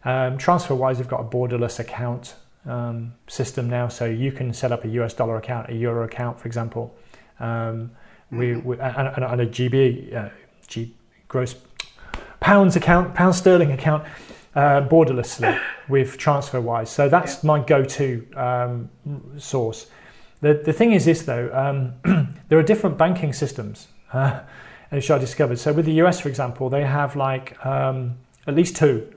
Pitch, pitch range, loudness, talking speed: 130 Hz, 120-150 Hz, -21 LUFS, 165 wpm